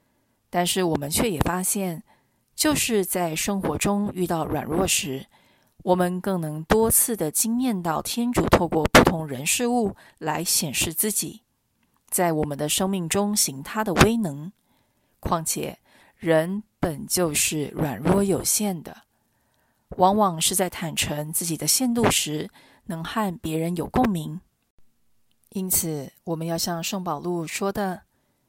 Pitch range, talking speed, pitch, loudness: 160-200 Hz, 200 characters per minute, 175 Hz, -23 LUFS